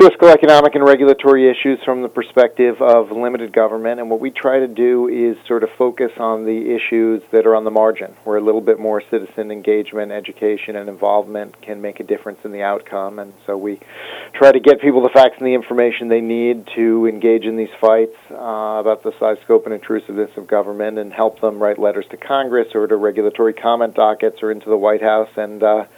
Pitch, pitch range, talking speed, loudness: 110 Hz, 105-120 Hz, 215 wpm, -15 LUFS